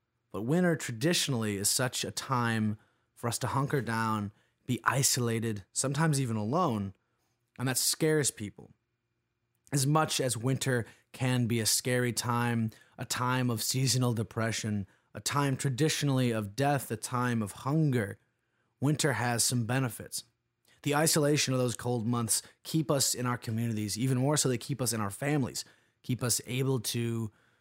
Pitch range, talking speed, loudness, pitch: 115-135 Hz, 155 wpm, -30 LUFS, 120 Hz